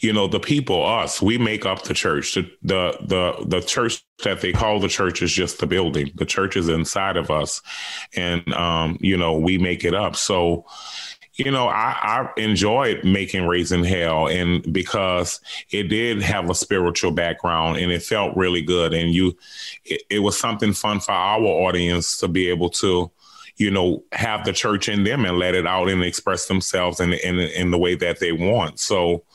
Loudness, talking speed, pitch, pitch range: -21 LUFS, 200 wpm, 90 Hz, 85-100 Hz